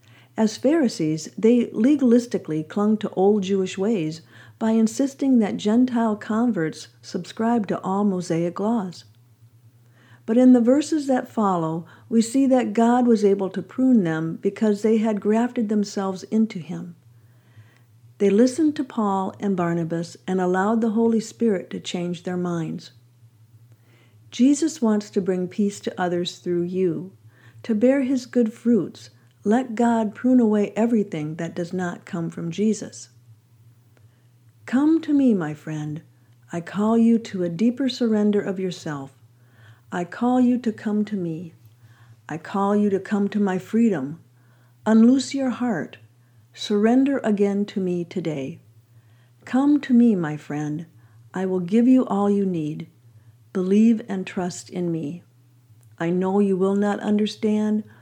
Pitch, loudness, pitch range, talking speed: 190 Hz, -22 LUFS, 150-225 Hz, 145 wpm